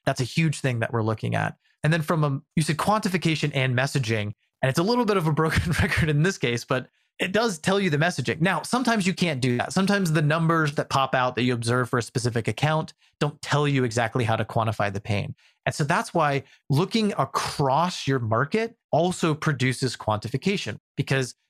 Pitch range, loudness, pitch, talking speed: 125-175 Hz, -24 LUFS, 150 Hz, 210 wpm